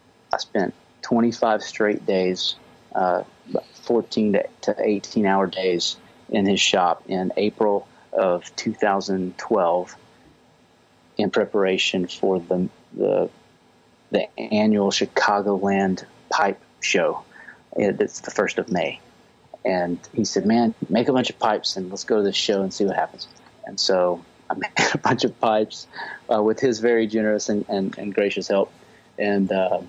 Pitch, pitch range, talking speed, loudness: 100 Hz, 90-105 Hz, 145 wpm, -22 LUFS